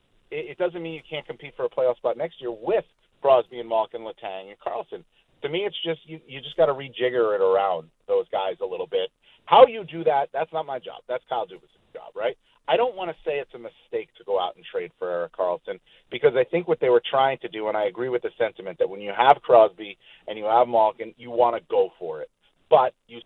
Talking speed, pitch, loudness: 245 wpm, 240 Hz, -24 LUFS